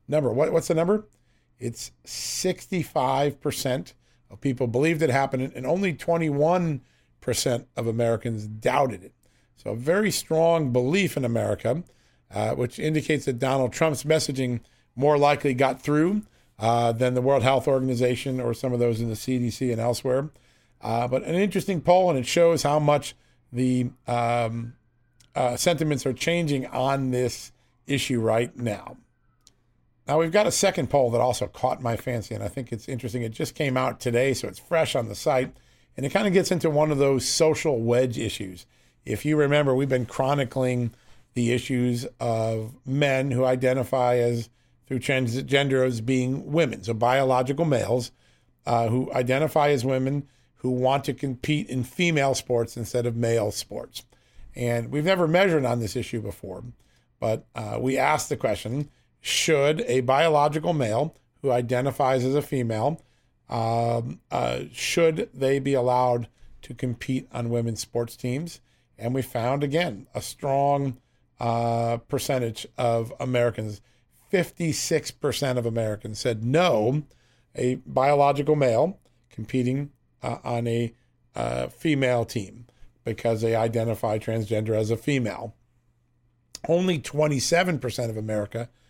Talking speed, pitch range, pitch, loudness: 150 wpm, 120-145 Hz, 125 Hz, -25 LUFS